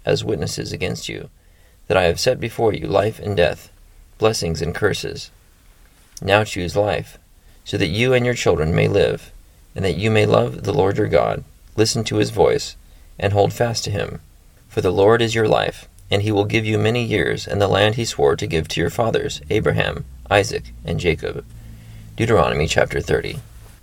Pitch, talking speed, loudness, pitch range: 100 Hz, 190 wpm, -19 LUFS, 85-110 Hz